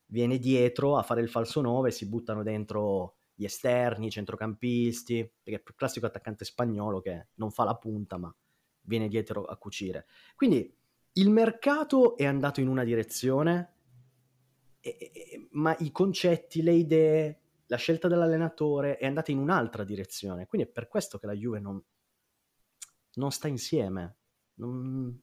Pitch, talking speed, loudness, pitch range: 120 Hz, 155 wpm, -29 LUFS, 110-150 Hz